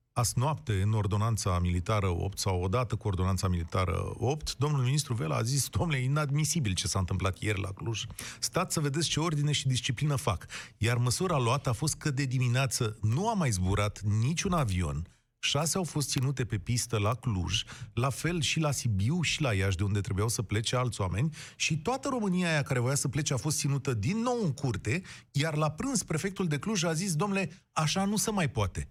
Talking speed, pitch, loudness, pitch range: 205 wpm, 130 Hz, -30 LUFS, 105-155 Hz